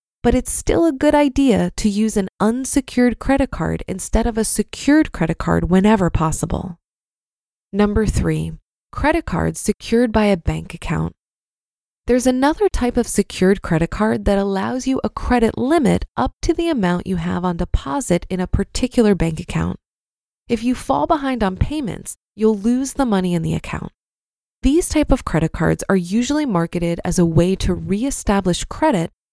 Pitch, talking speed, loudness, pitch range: 210 Hz, 170 wpm, -19 LUFS, 175-255 Hz